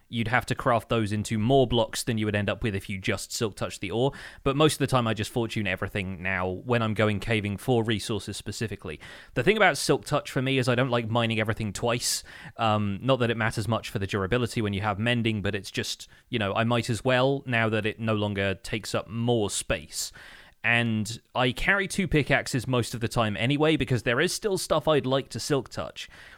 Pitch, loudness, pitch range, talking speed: 115 Hz, -26 LUFS, 105-125 Hz, 235 wpm